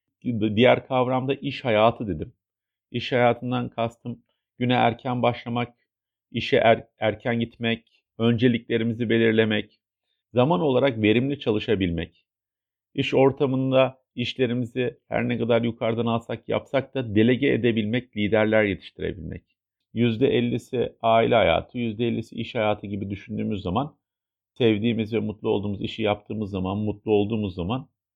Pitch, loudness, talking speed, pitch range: 115 Hz, -24 LUFS, 115 wpm, 105-125 Hz